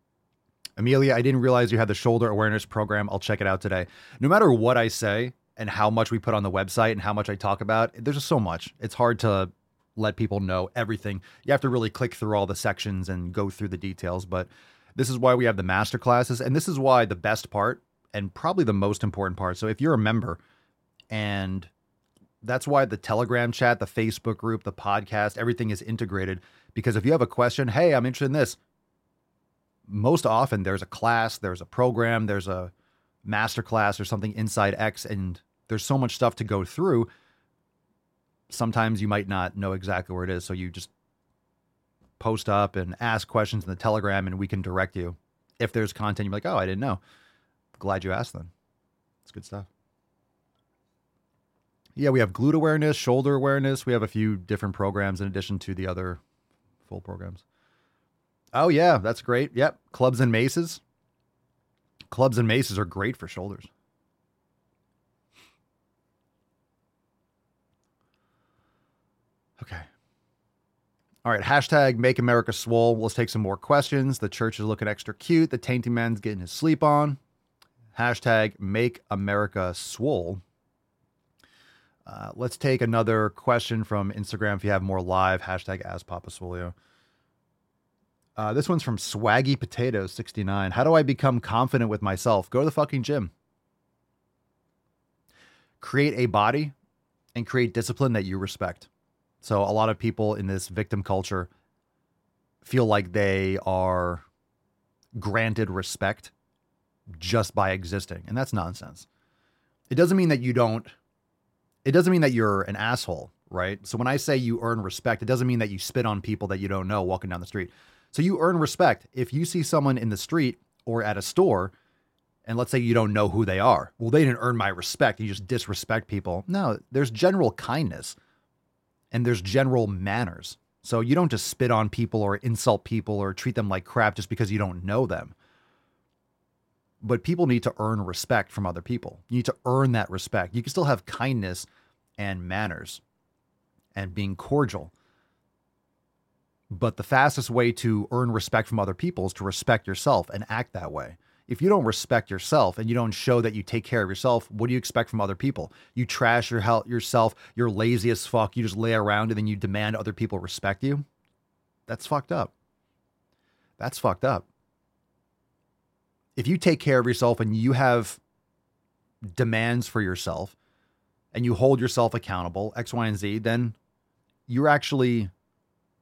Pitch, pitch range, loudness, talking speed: 110 Hz, 100-125 Hz, -25 LUFS, 180 wpm